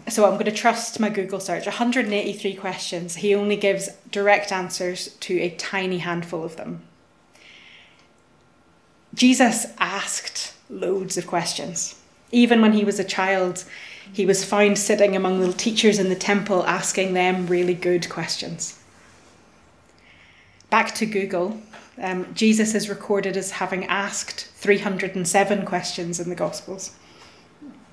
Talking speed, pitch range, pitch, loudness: 135 wpm, 180-205 Hz, 190 Hz, -22 LUFS